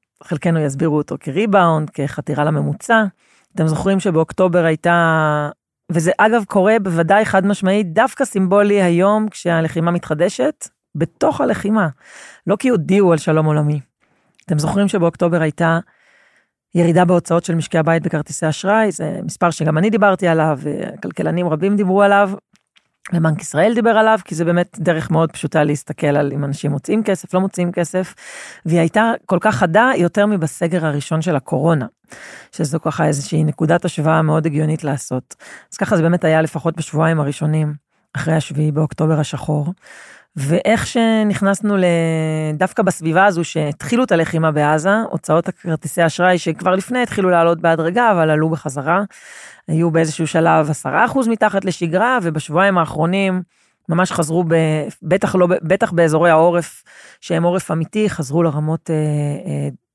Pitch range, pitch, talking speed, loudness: 155-195 Hz, 170 Hz, 140 wpm, -17 LUFS